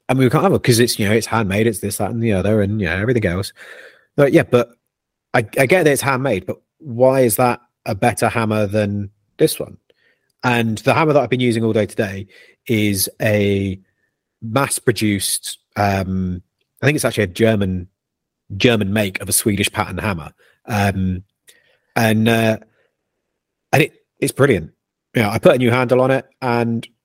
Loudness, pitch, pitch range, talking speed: -17 LUFS, 110 Hz, 100-125 Hz, 195 wpm